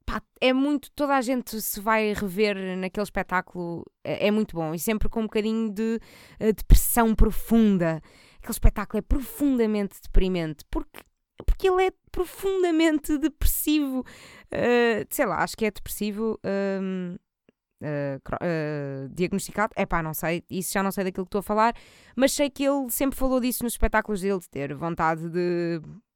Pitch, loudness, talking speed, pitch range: 210 Hz, -26 LUFS, 165 wpm, 180-245 Hz